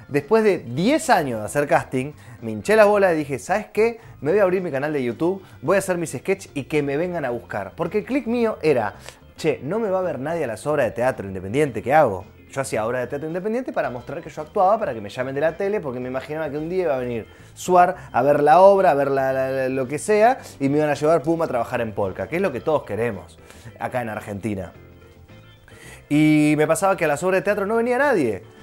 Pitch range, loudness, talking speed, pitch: 120-185 Hz, -21 LUFS, 260 wpm, 145 Hz